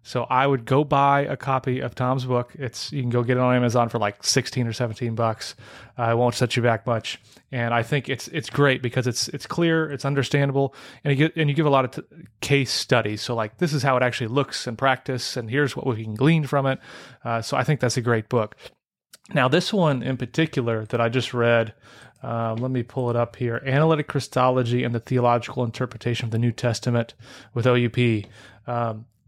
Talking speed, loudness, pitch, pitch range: 225 wpm, -23 LUFS, 125 Hz, 120-135 Hz